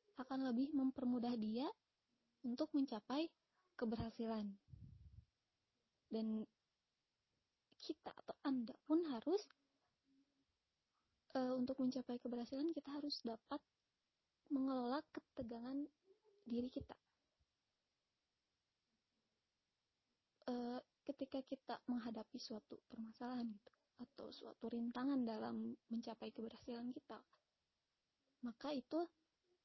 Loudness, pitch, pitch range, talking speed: -46 LUFS, 255 Hz, 235-285 Hz, 80 wpm